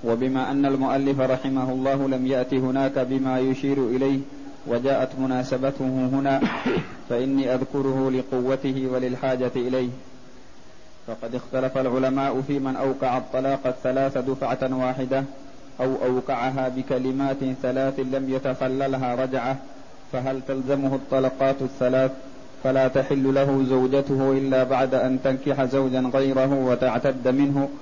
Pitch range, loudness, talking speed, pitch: 130-135 Hz, -24 LUFS, 110 wpm, 130 Hz